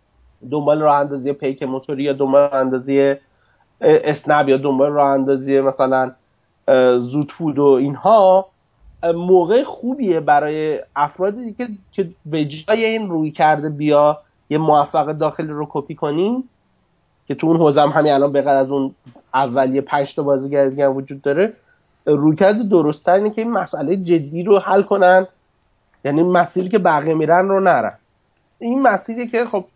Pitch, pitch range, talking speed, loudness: 150 Hz, 140-185 Hz, 145 wpm, -17 LUFS